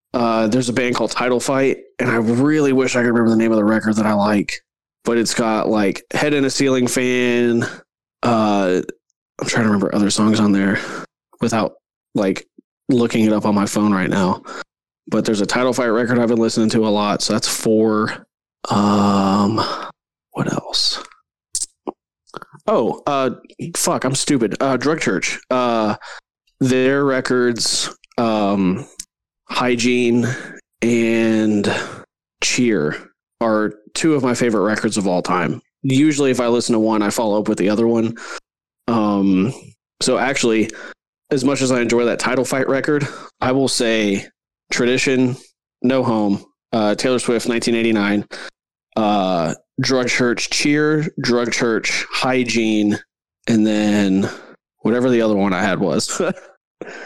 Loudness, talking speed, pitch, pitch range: -18 LUFS, 150 wpm, 115 Hz, 105-125 Hz